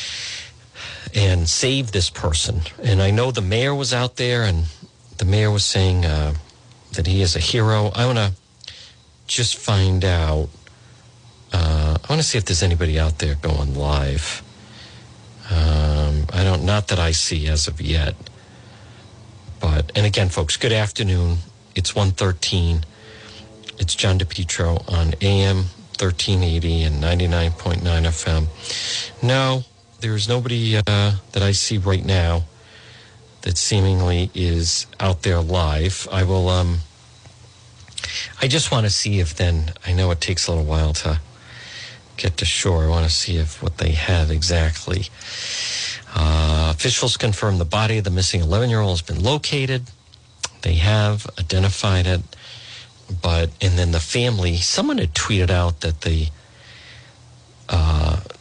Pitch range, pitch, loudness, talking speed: 85-110 Hz, 95 Hz, -20 LUFS, 150 wpm